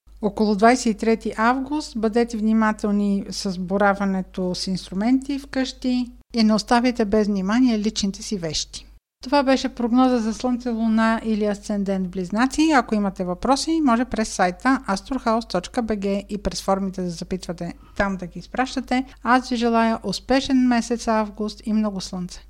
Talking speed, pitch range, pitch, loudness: 145 wpm, 200-250 Hz, 220 Hz, -22 LUFS